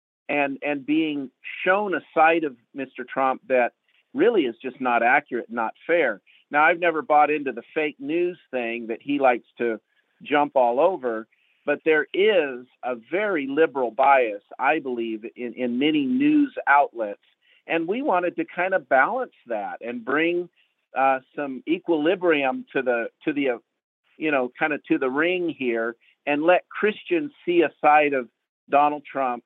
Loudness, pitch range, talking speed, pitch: -23 LUFS, 125-175 Hz, 165 wpm, 145 Hz